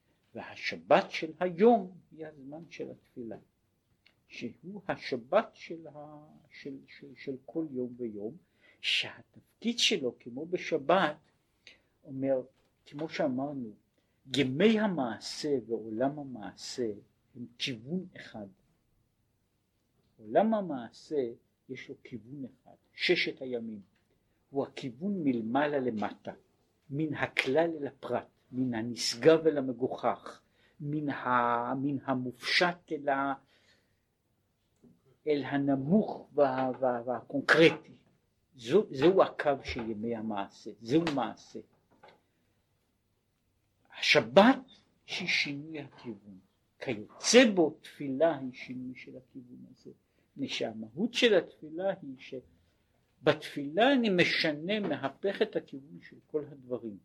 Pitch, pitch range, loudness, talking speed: 135 Hz, 115-160 Hz, -30 LUFS, 90 wpm